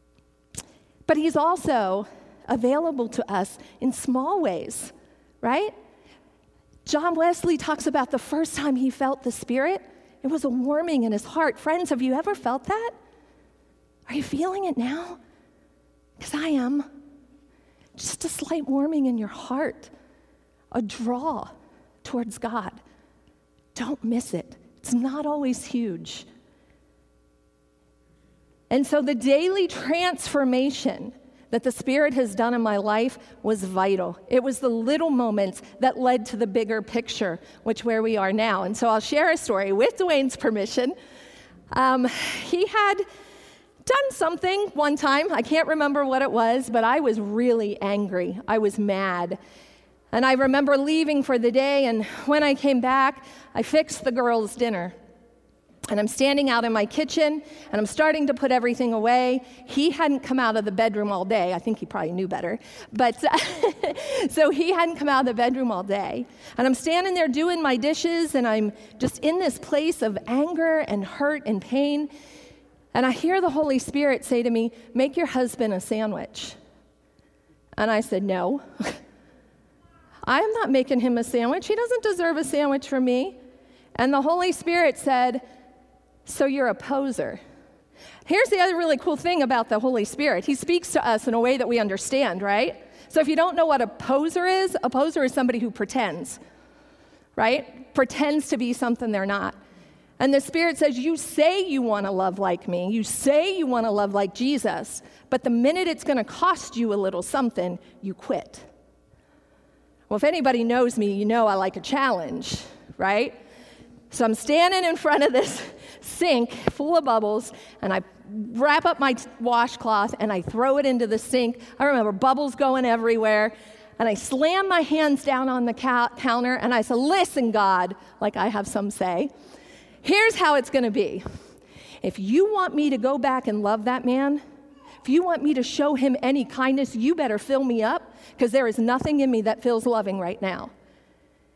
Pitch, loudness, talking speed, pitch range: 260 Hz, -24 LUFS, 175 wpm, 225-295 Hz